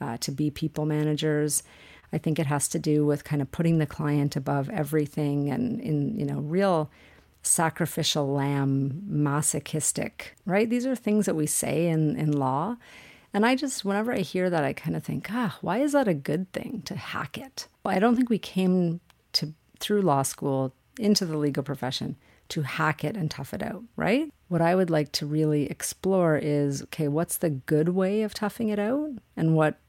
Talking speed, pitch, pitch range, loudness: 200 wpm, 160 Hz, 145-195 Hz, -27 LUFS